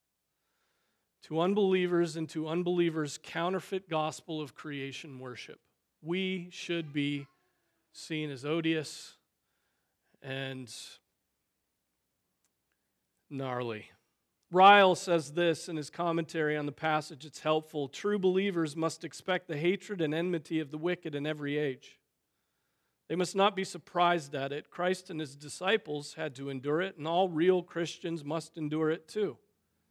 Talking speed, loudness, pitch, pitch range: 130 wpm, -31 LUFS, 160 Hz, 150-175 Hz